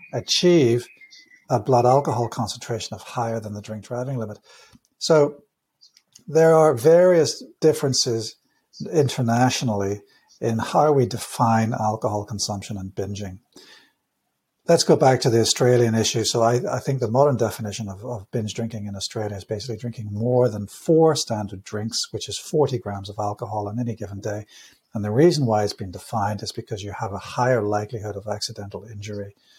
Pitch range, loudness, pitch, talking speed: 105-130 Hz, -22 LUFS, 115 Hz, 165 wpm